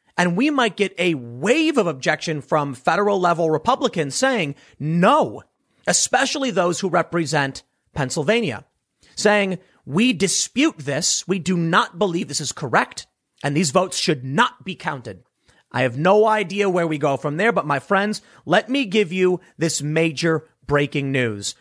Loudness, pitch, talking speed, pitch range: -20 LUFS, 175 Hz, 160 wpm, 150-205 Hz